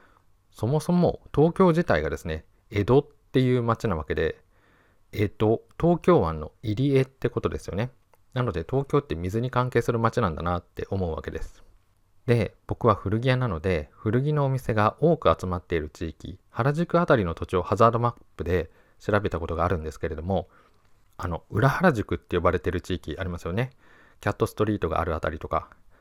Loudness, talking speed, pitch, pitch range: -26 LUFS, 365 characters per minute, 105 Hz, 90-125 Hz